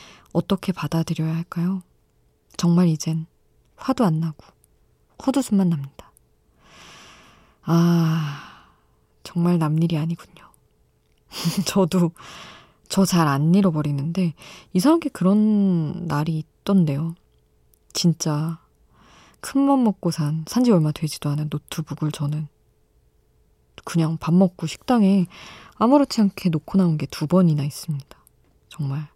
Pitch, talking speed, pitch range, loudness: 165 Hz, 230 characters per minute, 150-185 Hz, -22 LUFS